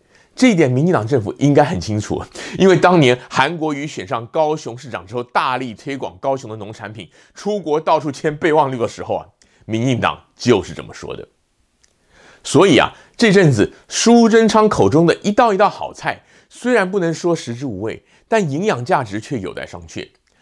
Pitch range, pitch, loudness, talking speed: 125-180 Hz, 150 Hz, -16 LUFS, 280 characters per minute